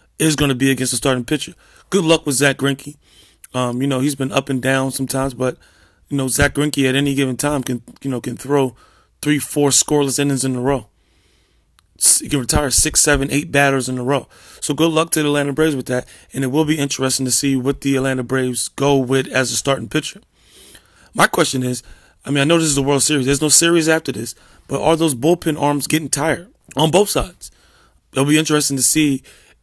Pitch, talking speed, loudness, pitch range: 140 Hz, 225 wpm, -17 LUFS, 130-150 Hz